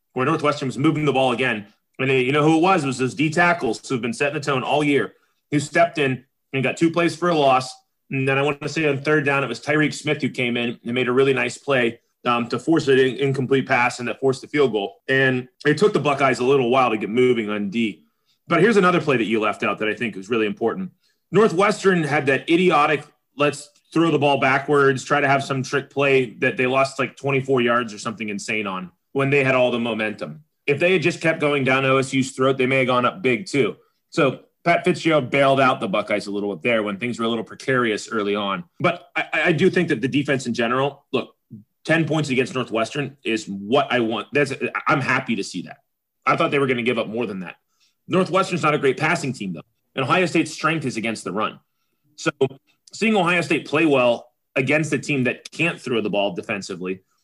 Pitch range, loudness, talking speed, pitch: 125-150 Hz, -20 LUFS, 240 wpm, 135 Hz